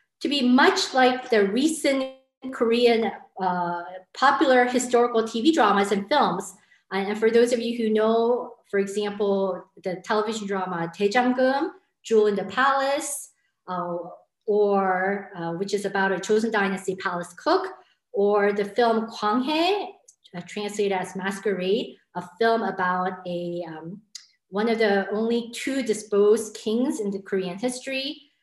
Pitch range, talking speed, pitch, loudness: 195-250 Hz, 135 wpm, 215 Hz, -24 LUFS